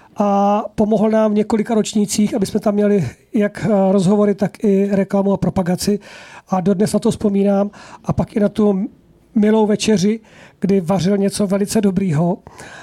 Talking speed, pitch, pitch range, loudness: 160 wpm, 205 Hz, 195-215 Hz, -17 LUFS